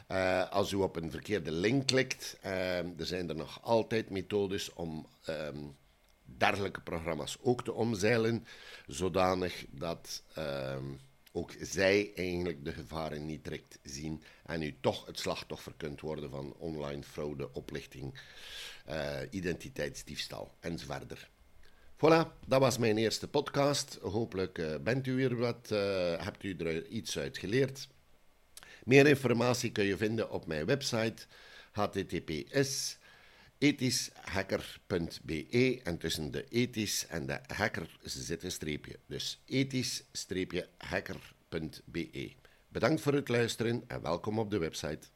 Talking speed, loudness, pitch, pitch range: 130 wpm, -34 LUFS, 95 Hz, 80-120 Hz